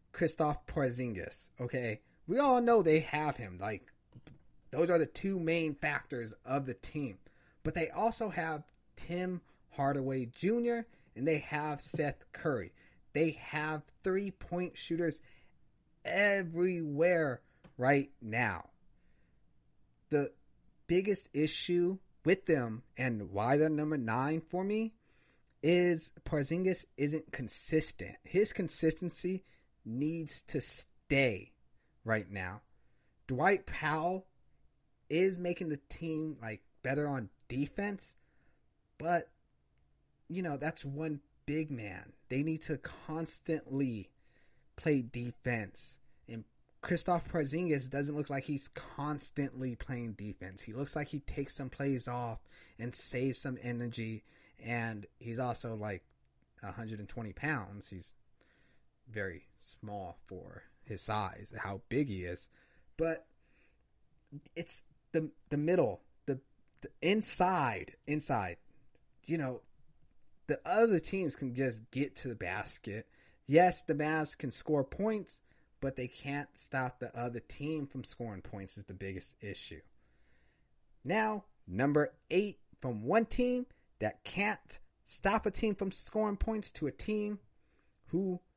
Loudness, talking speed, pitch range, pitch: -36 LUFS, 120 wpm, 120-170 Hz, 145 Hz